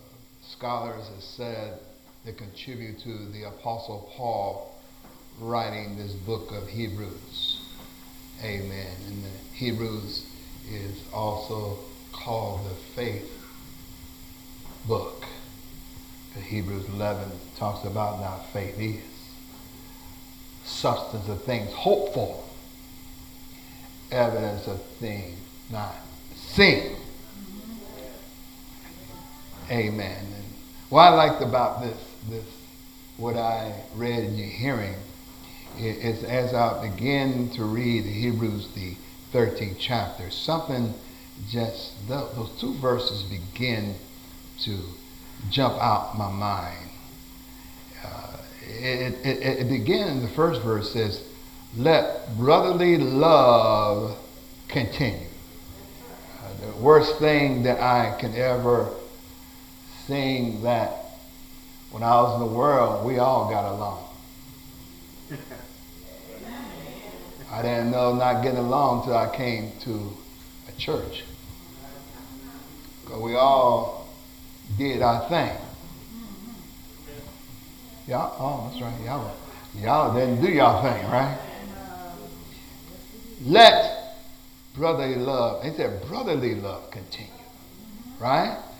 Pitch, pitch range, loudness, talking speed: 115 Hz, 100-130 Hz, -24 LUFS, 100 wpm